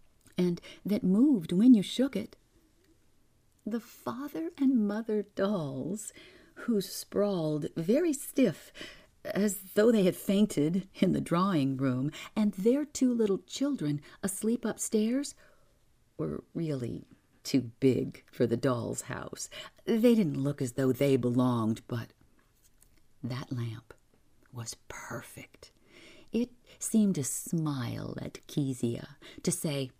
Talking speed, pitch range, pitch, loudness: 120 wpm, 135-225 Hz, 190 Hz, -30 LUFS